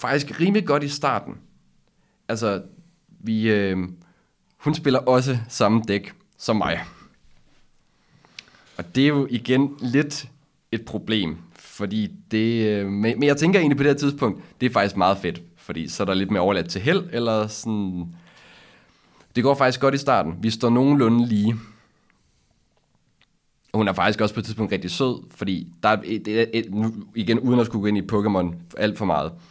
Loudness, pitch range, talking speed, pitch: -22 LUFS, 105-140 Hz, 170 wpm, 115 Hz